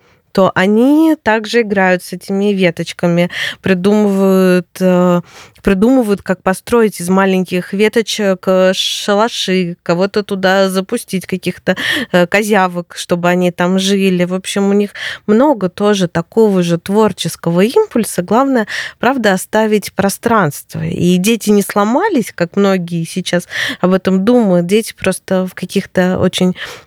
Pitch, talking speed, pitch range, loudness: 190 Hz, 120 wpm, 180-215 Hz, -13 LUFS